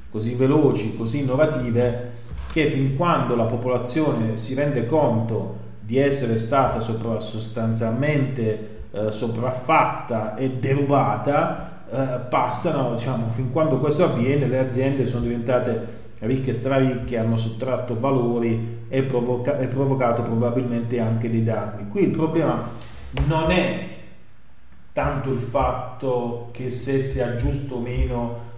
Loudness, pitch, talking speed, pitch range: -23 LUFS, 125 Hz, 125 wpm, 115-135 Hz